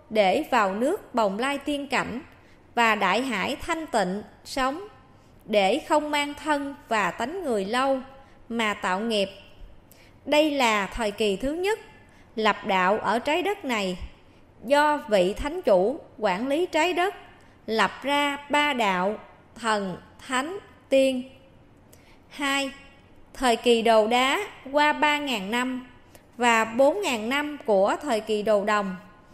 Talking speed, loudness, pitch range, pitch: 145 wpm, -24 LUFS, 215-290 Hz, 255 Hz